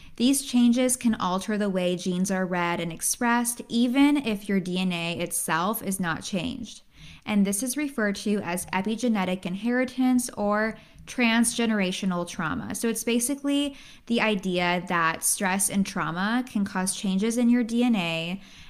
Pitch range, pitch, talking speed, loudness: 185-240 Hz, 210 Hz, 145 wpm, -25 LUFS